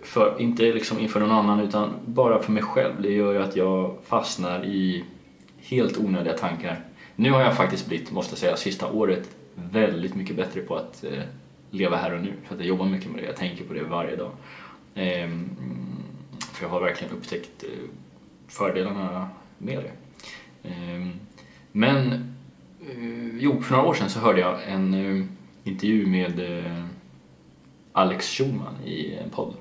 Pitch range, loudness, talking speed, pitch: 85-105 Hz, -25 LUFS, 170 wpm, 95 Hz